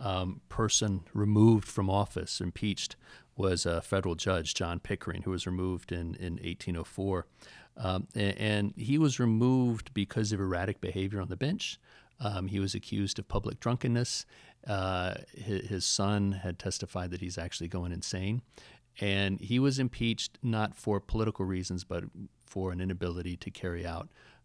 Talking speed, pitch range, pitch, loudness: 155 wpm, 90-110 Hz, 100 Hz, -32 LUFS